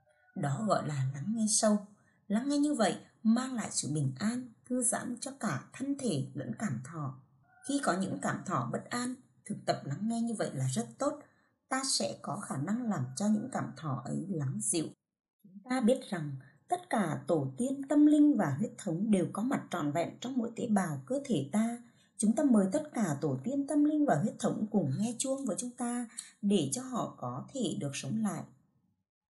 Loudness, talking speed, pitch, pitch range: -33 LUFS, 215 wpm, 220 Hz, 170-255 Hz